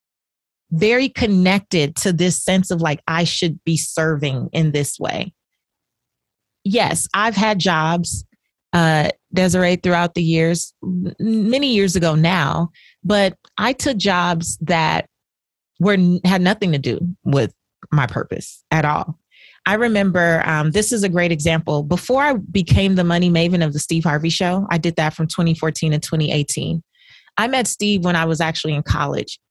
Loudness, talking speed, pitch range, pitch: -18 LUFS, 155 wpm, 160-190 Hz, 170 Hz